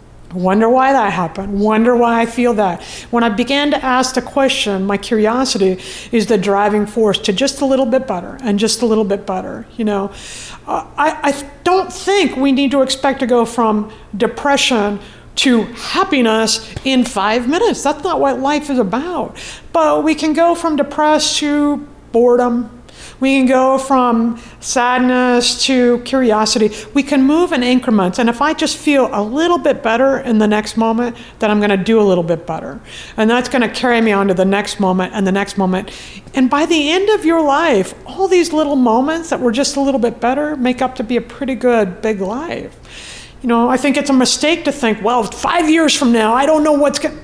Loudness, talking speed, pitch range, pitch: -14 LUFS, 205 wpm, 220-280 Hz, 250 Hz